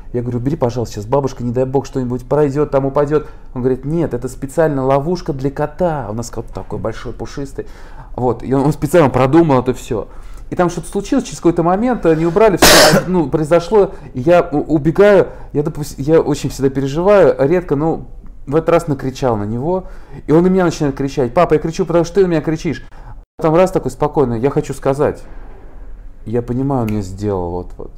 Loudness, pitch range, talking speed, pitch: -15 LUFS, 125-165 Hz, 195 wpm, 140 Hz